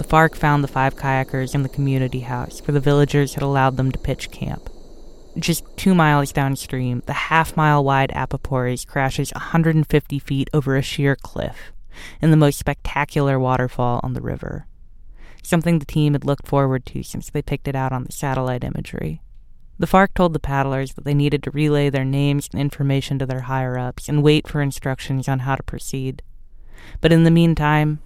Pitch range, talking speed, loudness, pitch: 130-150 Hz, 190 wpm, -20 LUFS, 140 Hz